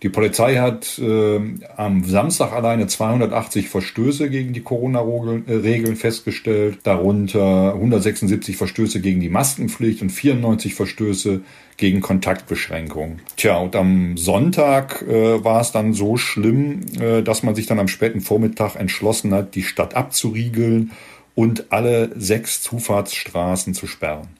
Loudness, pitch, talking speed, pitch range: -19 LUFS, 110 Hz, 130 wpm, 100-115 Hz